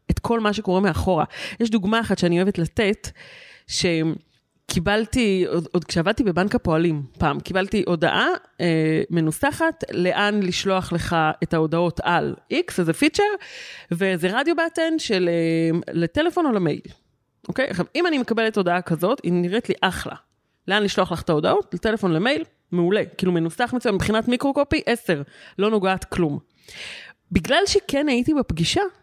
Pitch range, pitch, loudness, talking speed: 175-245 Hz, 195 Hz, -22 LUFS, 150 wpm